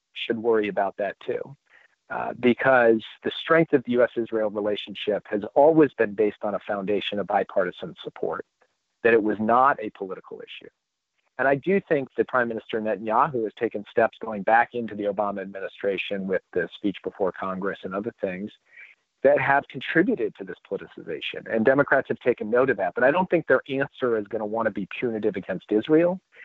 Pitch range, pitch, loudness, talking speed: 105-165 Hz, 125 Hz, -24 LUFS, 190 wpm